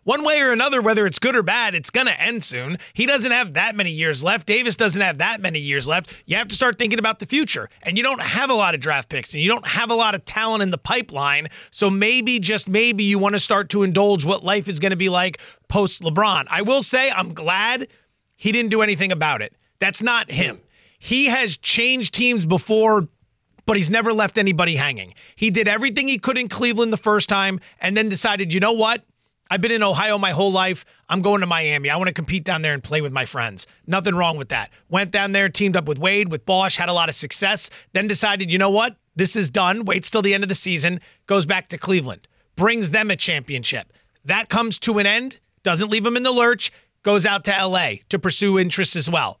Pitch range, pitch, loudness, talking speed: 175-220 Hz, 200 Hz, -19 LUFS, 240 wpm